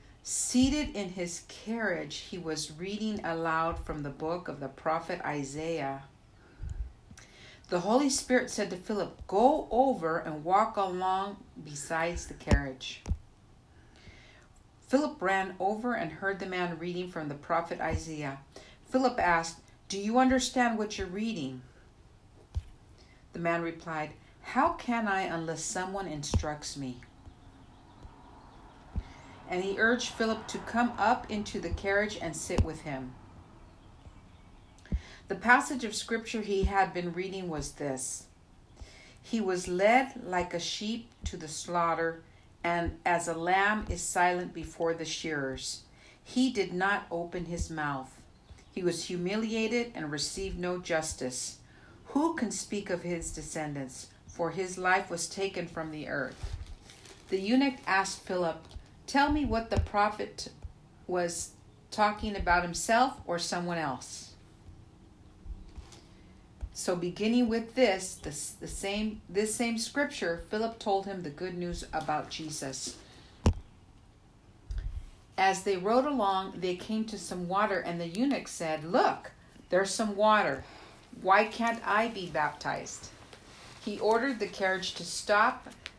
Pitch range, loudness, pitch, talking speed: 135-205 Hz, -31 LUFS, 175 Hz, 135 wpm